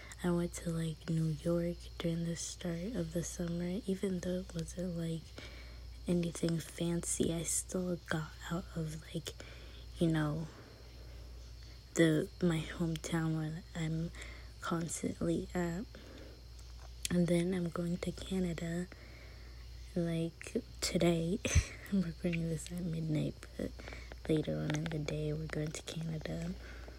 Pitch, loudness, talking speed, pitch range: 165 Hz, -37 LUFS, 125 wpm, 150-175 Hz